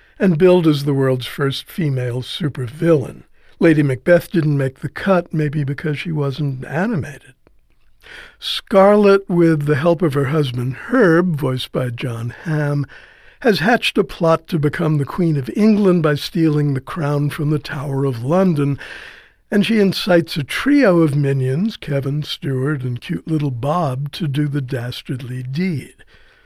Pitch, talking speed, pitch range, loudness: 150 Hz, 155 wpm, 140-175 Hz, -18 LUFS